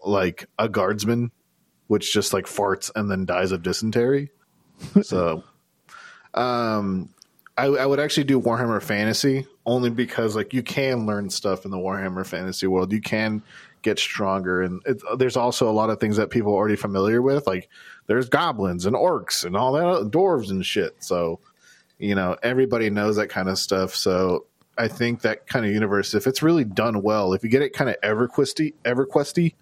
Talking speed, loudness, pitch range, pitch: 185 wpm, -23 LUFS, 100-130 Hz, 110 Hz